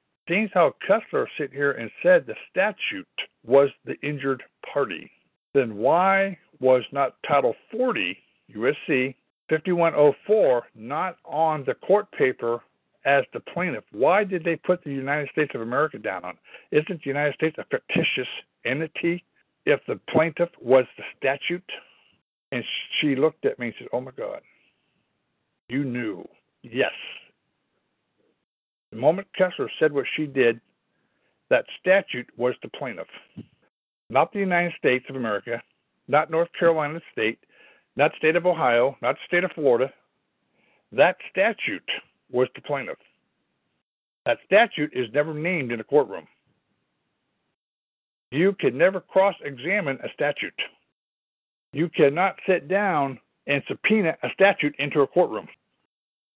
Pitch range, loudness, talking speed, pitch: 135-175 Hz, -24 LUFS, 135 wpm, 150 Hz